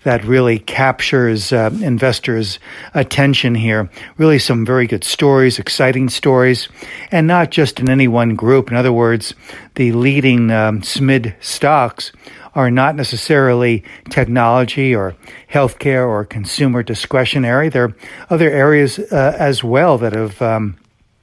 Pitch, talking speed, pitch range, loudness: 125 Hz, 135 wpm, 115-135 Hz, -14 LUFS